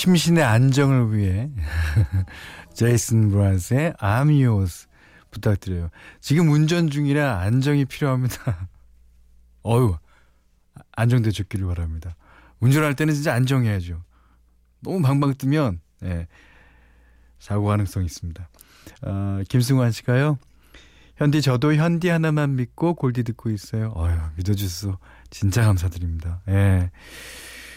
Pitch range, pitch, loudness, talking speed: 85-130 Hz, 100 Hz, -22 LUFS, 260 characters per minute